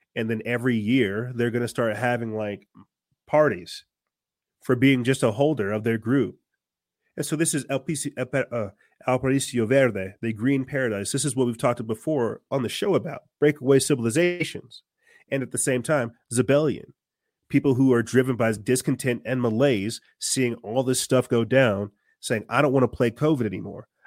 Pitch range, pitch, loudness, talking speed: 115-140 Hz, 125 Hz, -24 LUFS, 175 wpm